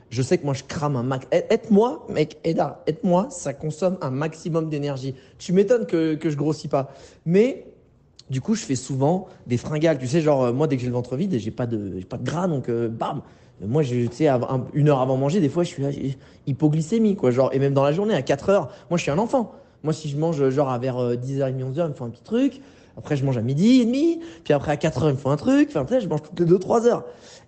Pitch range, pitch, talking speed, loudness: 130-180 Hz, 150 Hz, 270 wpm, -23 LUFS